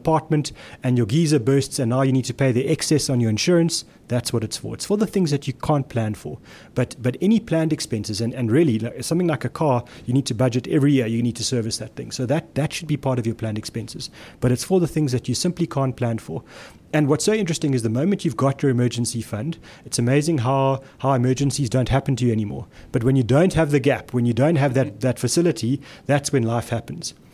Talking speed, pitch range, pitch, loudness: 250 wpm, 120-150 Hz, 135 Hz, -22 LUFS